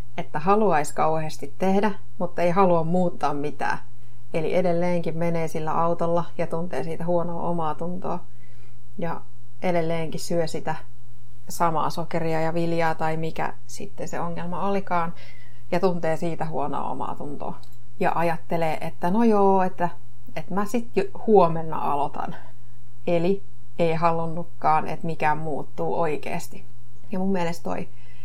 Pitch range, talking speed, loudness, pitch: 135-175 Hz, 135 wpm, -26 LUFS, 165 Hz